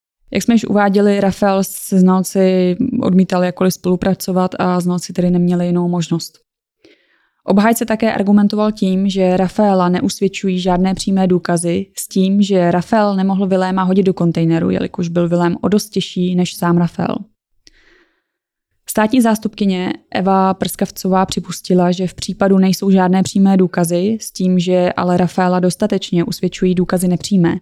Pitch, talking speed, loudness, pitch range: 185 Hz, 140 wpm, -15 LUFS, 180-200 Hz